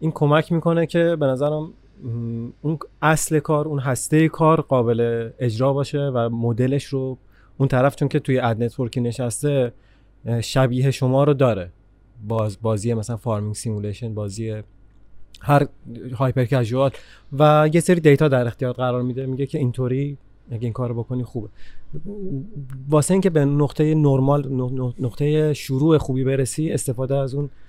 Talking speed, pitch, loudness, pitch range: 145 wpm, 130 Hz, -21 LUFS, 115-145 Hz